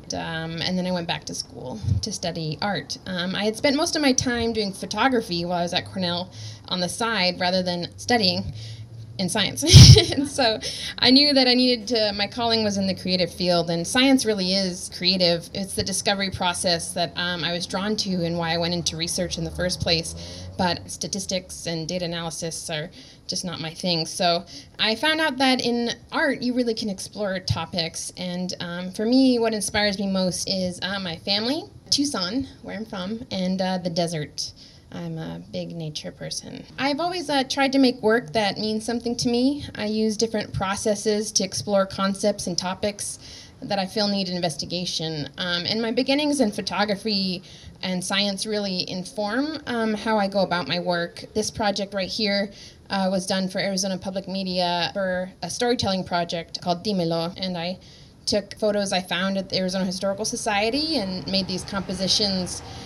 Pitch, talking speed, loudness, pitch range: 190 Hz, 185 wpm, -23 LUFS, 175-215 Hz